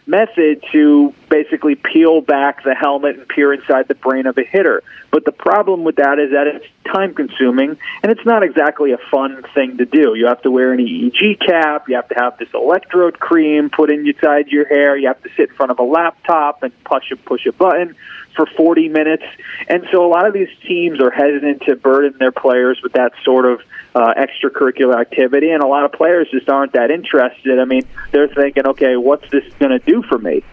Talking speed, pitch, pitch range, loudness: 220 wpm, 145 Hz, 130-165 Hz, -14 LUFS